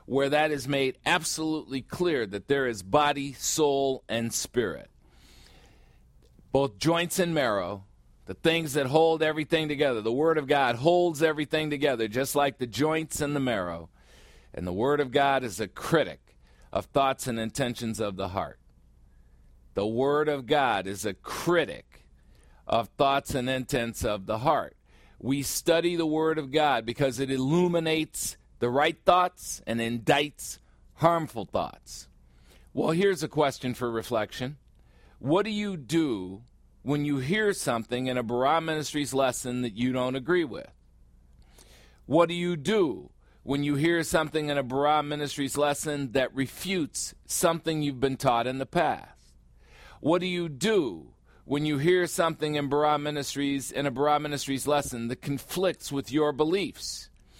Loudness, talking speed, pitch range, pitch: -27 LUFS, 155 wpm, 115-155 Hz, 140 Hz